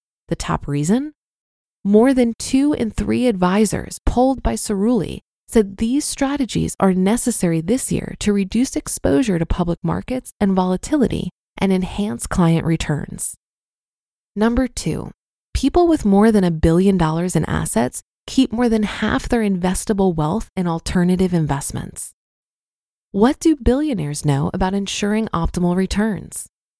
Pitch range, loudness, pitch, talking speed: 180-240 Hz, -19 LUFS, 205 Hz, 135 wpm